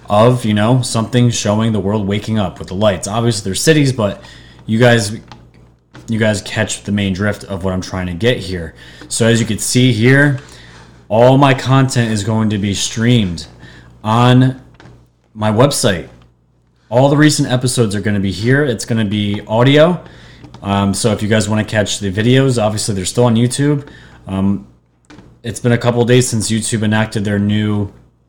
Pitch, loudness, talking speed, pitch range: 110 Hz, -14 LUFS, 190 wpm, 95-120 Hz